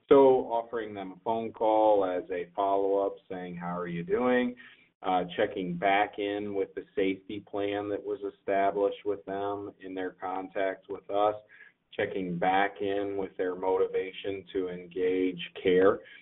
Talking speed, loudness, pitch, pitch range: 155 wpm, -30 LUFS, 100 Hz, 95-105 Hz